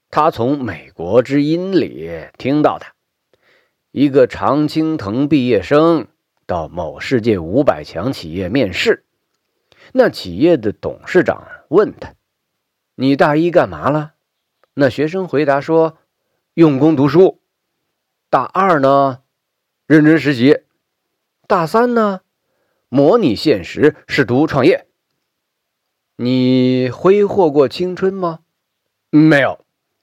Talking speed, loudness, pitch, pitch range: 160 characters per minute, -15 LUFS, 155 Hz, 140-175 Hz